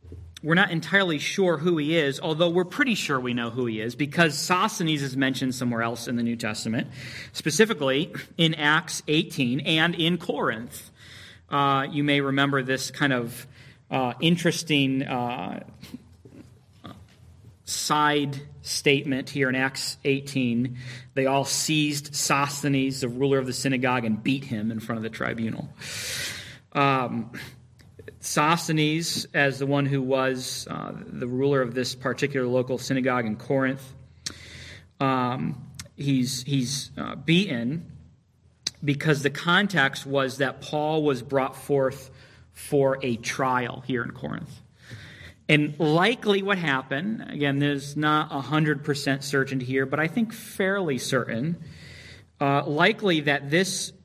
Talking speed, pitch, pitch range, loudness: 135 wpm, 140 Hz, 130-150 Hz, -25 LUFS